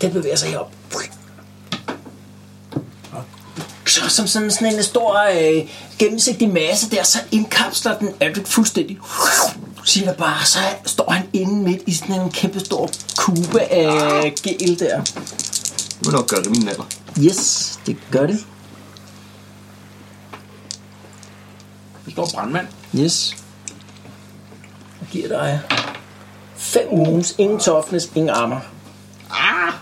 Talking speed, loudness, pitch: 125 wpm, -18 LUFS, 150 Hz